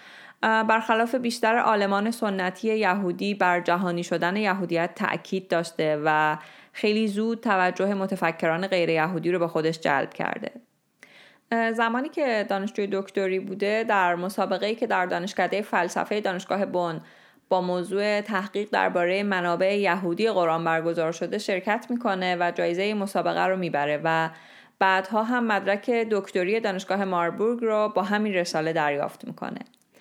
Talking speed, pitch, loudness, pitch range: 130 wpm, 190 Hz, -25 LUFS, 175-215 Hz